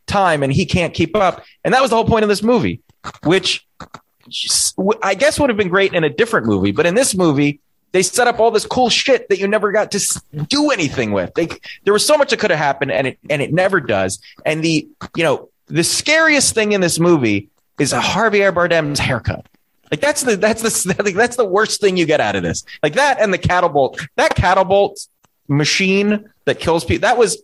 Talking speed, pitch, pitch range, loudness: 230 wpm, 195 Hz, 165-225 Hz, -16 LUFS